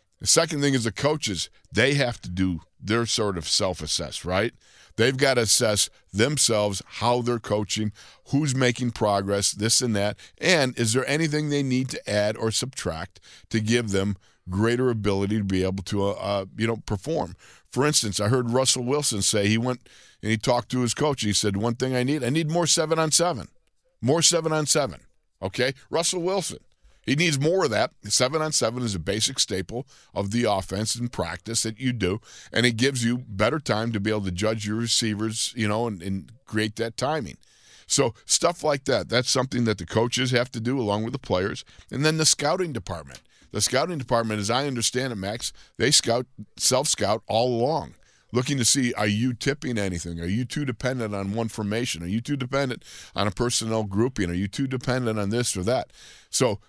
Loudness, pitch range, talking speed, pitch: -24 LUFS, 105-130 Hz, 205 wpm, 115 Hz